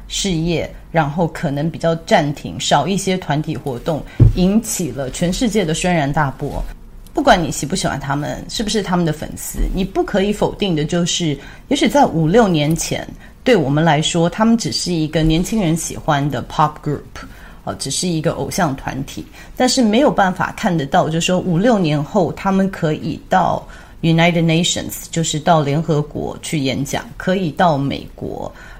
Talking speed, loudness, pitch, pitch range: 300 characters per minute, -17 LUFS, 165 Hz, 145-185 Hz